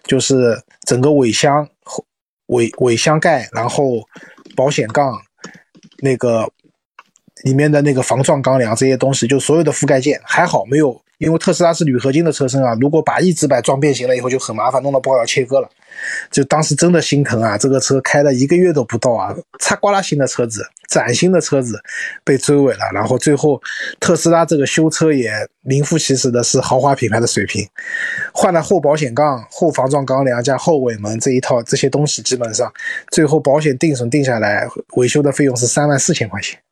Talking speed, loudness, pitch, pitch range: 300 characters per minute, -15 LUFS, 140 Hz, 125-150 Hz